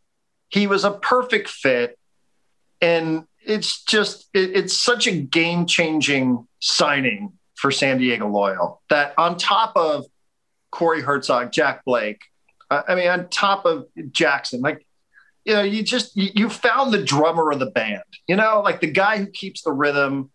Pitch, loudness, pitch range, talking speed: 185 Hz, -20 LUFS, 150-205 Hz, 160 wpm